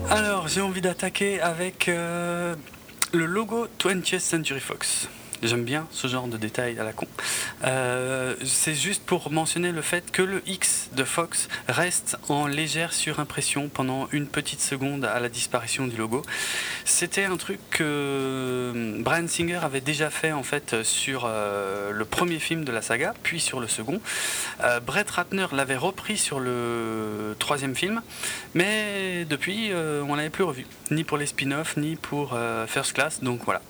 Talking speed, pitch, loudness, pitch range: 170 wpm, 150 Hz, -26 LUFS, 130-175 Hz